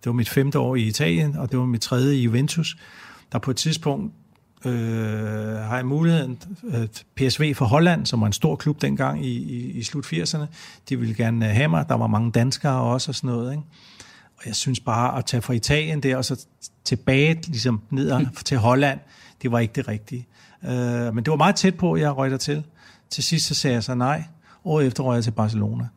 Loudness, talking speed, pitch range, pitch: -22 LUFS, 225 wpm, 120-150 Hz, 130 Hz